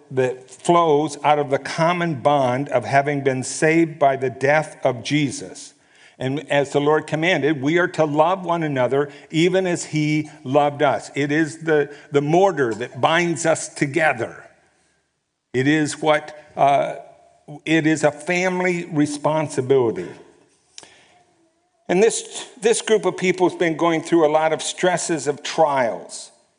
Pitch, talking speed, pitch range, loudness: 155 Hz, 150 wpm, 145-175 Hz, -20 LUFS